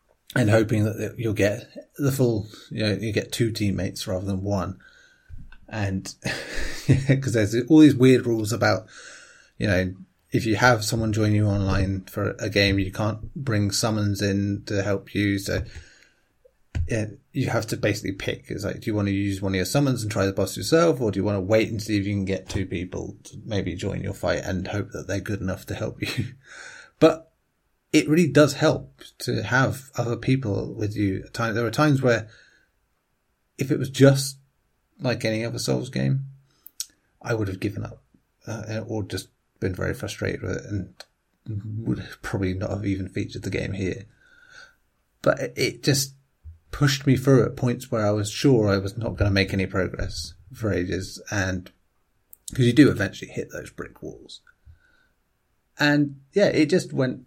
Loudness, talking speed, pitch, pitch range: -24 LUFS, 185 wpm, 110 Hz, 95-130 Hz